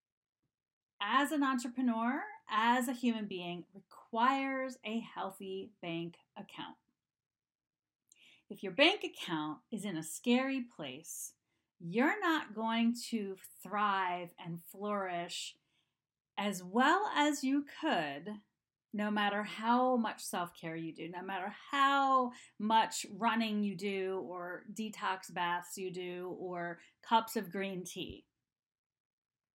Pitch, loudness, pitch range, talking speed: 210 Hz, -35 LUFS, 180-250 Hz, 120 wpm